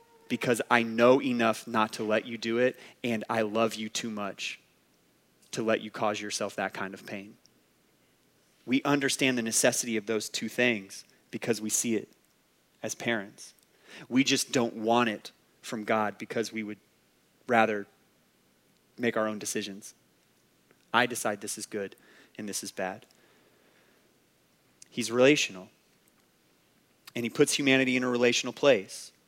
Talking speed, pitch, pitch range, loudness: 150 wpm, 115 Hz, 110-125 Hz, -28 LUFS